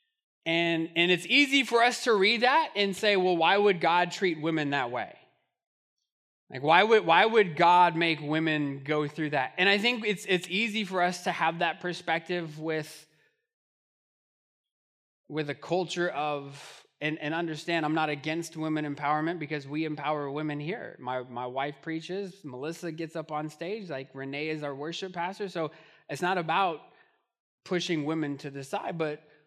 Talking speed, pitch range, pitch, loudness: 175 wpm, 150-185 Hz, 165 Hz, -28 LUFS